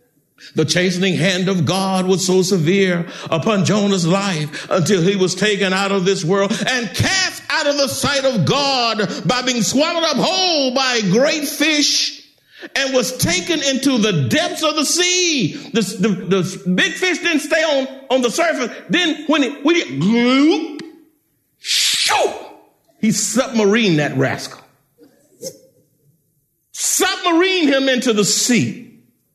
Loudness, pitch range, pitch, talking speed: -16 LUFS, 190-295 Hz, 235 Hz, 155 wpm